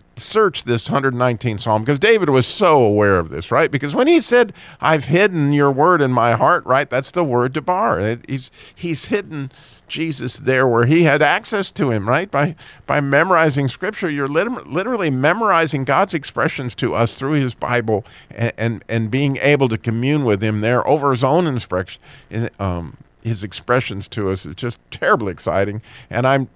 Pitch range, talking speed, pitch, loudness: 115-150 Hz, 185 wpm, 130 Hz, -17 LUFS